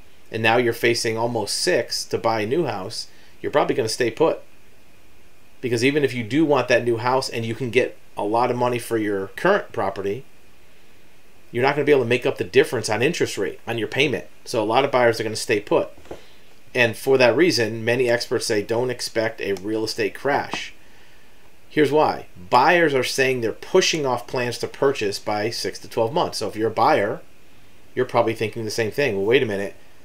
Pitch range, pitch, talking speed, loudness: 110-130 Hz, 120 Hz, 220 wpm, -21 LUFS